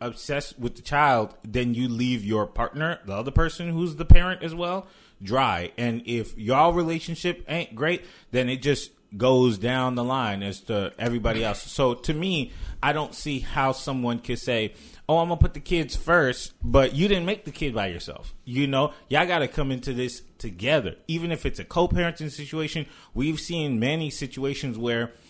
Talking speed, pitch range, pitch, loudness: 185 wpm, 120-160 Hz, 135 Hz, -25 LUFS